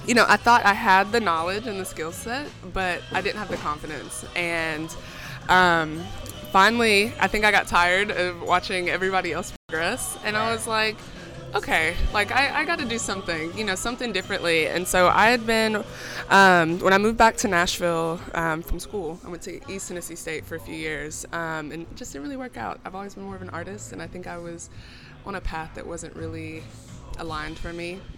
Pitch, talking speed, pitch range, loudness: 180 Hz, 215 wpm, 165-210 Hz, -22 LUFS